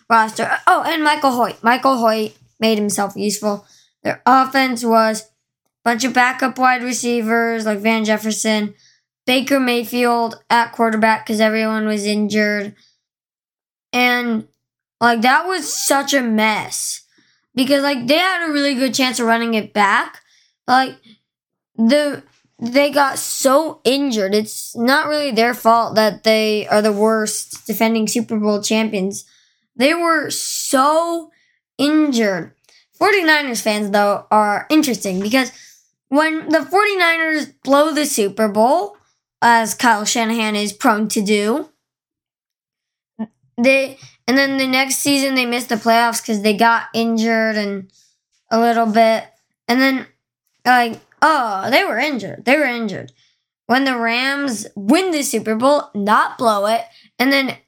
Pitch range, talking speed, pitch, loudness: 220-270 Hz, 140 wpm, 235 Hz, -16 LUFS